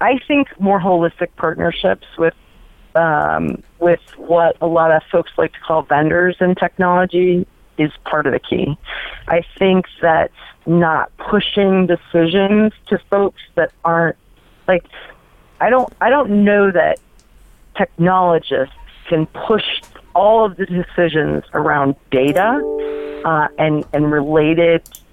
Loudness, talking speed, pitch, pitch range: -16 LUFS, 130 wpm, 170 Hz, 155-190 Hz